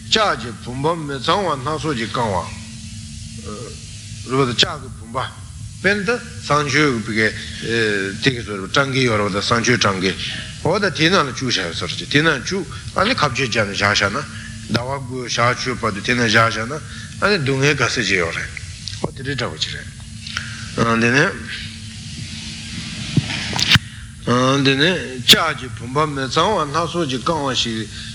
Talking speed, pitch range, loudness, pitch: 200 wpm, 110-140 Hz, -18 LUFS, 120 Hz